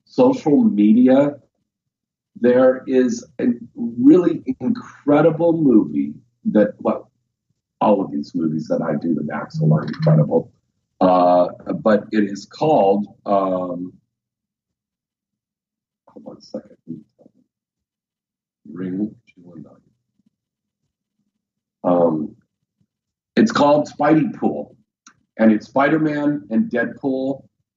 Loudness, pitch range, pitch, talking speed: -18 LUFS, 95-160 Hz, 125 Hz, 95 wpm